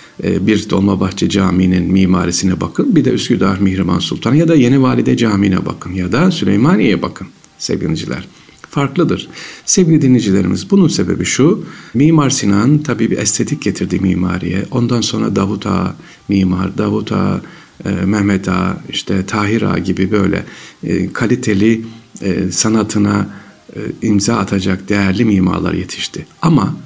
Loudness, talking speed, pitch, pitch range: -14 LUFS, 125 wpm, 100 Hz, 95-115 Hz